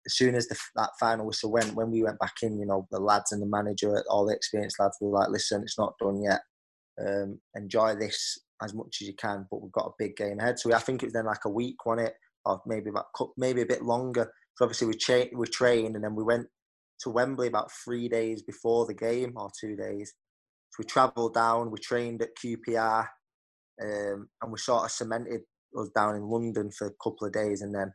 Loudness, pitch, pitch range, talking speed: -30 LUFS, 110 Hz, 105-120 Hz, 245 wpm